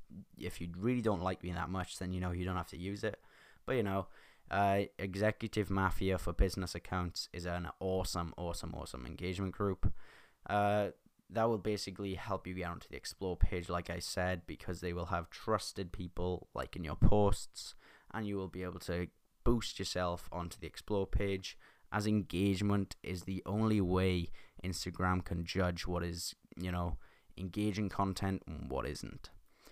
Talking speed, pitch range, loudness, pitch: 175 wpm, 85-100 Hz, -38 LUFS, 90 Hz